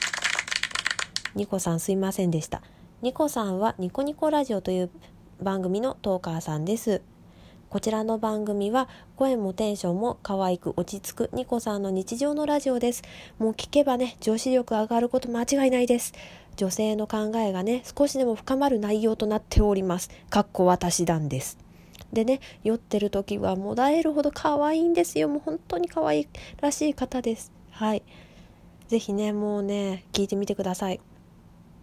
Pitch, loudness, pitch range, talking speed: 215 Hz, -26 LUFS, 195-255 Hz, 335 characters per minute